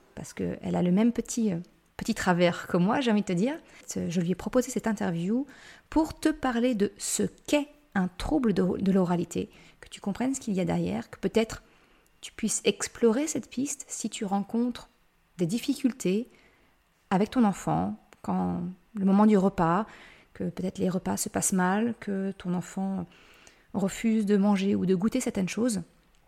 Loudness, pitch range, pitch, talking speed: -28 LUFS, 185-235 Hz, 205 Hz, 175 wpm